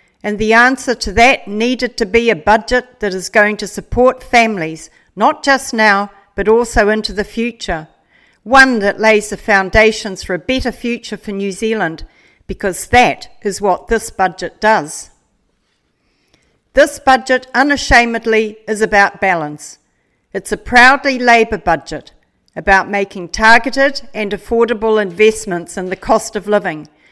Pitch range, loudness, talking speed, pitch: 200-240 Hz, -13 LUFS, 145 wpm, 220 Hz